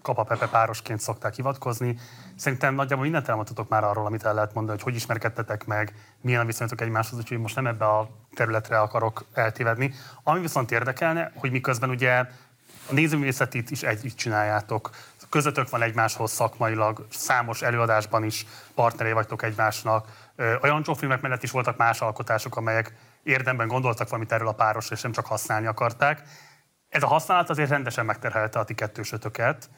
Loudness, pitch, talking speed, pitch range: -25 LUFS, 115 Hz, 160 wpm, 110-130 Hz